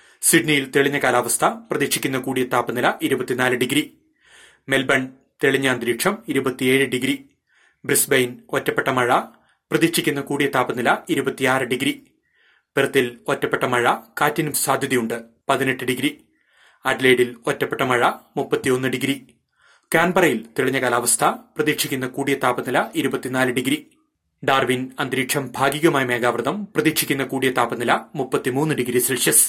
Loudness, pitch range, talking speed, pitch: -20 LUFS, 130-150 Hz, 100 wpm, 135 Hz